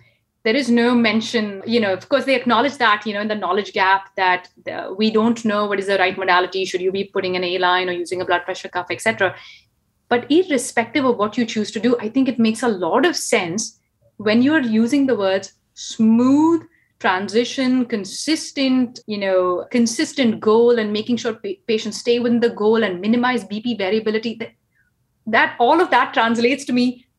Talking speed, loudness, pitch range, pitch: 200 wpm, -18 LUFS, 195-245 Hz, 225 Hz